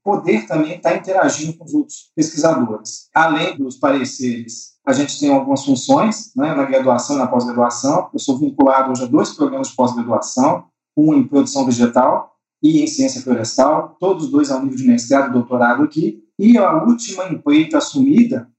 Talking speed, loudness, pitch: 175 wpm, -16 LUFS, 170 Hz